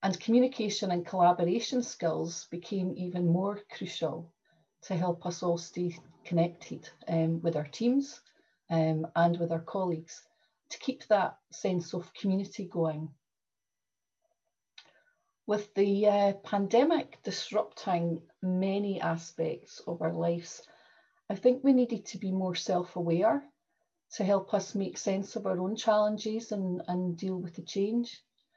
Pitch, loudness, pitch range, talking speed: 190 Hz, -31 LUFS, 170-220 Hz, 135 wpm